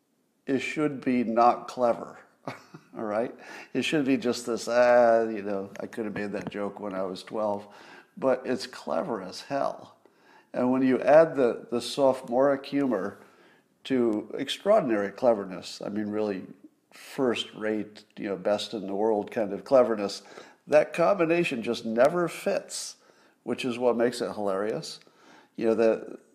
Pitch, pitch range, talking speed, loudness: 115 Hz, 105-130 Hz, 160 wpm, -27 LUFS